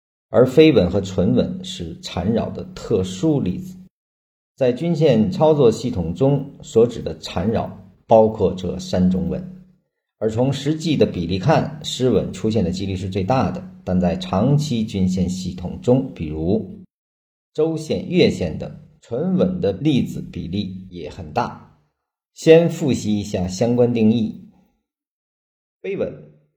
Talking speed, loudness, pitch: 200 characters per minute, -20 LUFS, 110 Hz